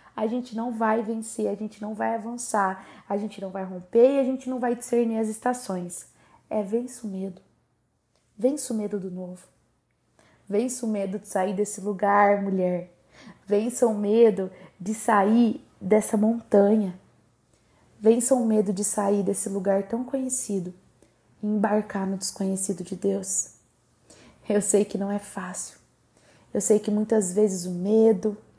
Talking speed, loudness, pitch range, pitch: 155 wpm, -25 LUFS, 195-225 Hz, 210 Hz